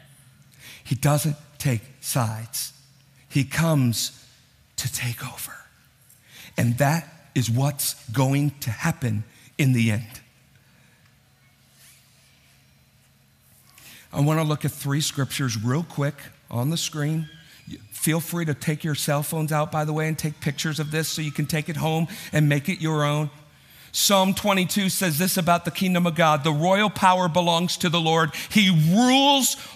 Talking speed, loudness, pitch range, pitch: 155 wpm, -23 LUFS, 135-165 Hz, 150 Hz